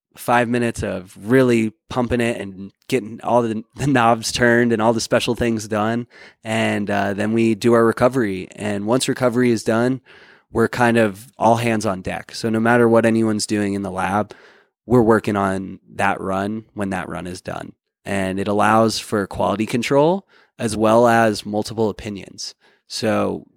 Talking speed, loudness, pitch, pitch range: 175 wpm, -19 LUFS, 110 Hz, 100-120 Hz